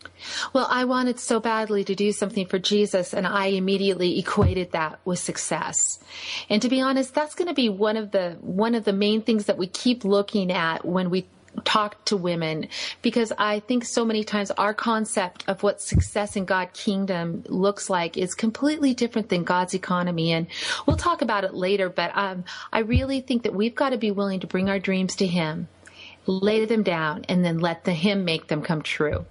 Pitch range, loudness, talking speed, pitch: 185-225 Hz, -24 LUFS, 205 wpm, 200 Hz